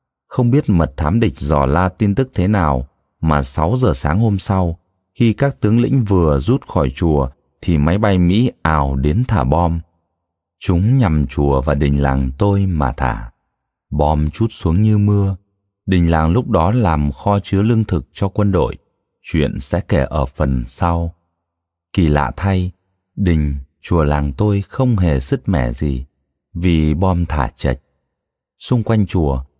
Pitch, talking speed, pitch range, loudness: 85 Hz, 170 wpm, 75-100 Hz, -17 LUFS